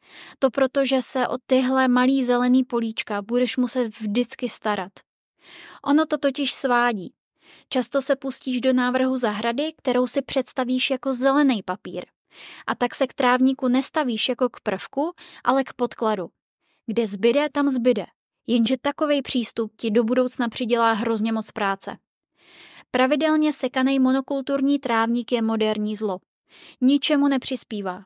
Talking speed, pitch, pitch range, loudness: 135 wpm, 255 Hz, 235-275 Hz, -22 LUFS